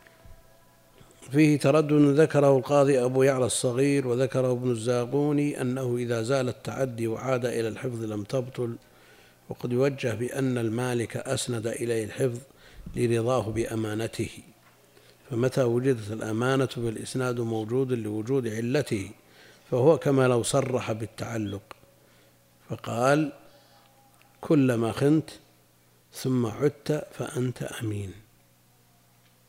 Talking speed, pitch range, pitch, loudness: 95 wpm, 110-135 Hz, 125 Hz, -26 LUFS